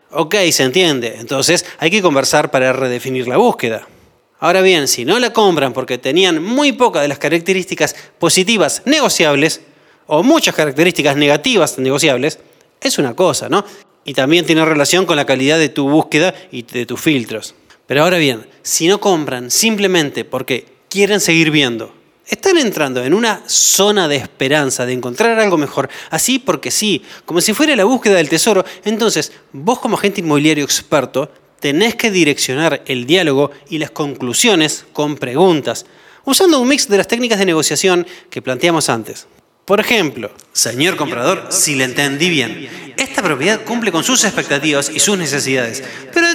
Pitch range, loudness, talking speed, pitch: 140-200 Hz, -13 LUFS, 165 wpm, 160 Hz